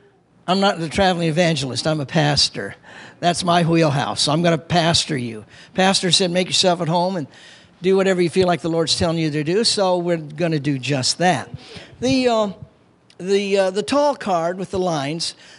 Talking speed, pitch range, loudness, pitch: 195 wpm, 150-185 Hz, -19 LUFS, 170 Hz